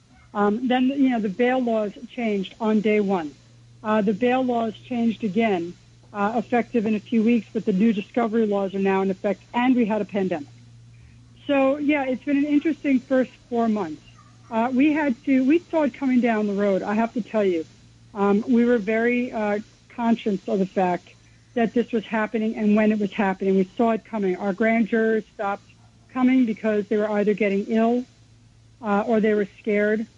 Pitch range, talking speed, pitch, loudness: 200-235 Hz, 200 wpm, 220 Hz, -23 LUFS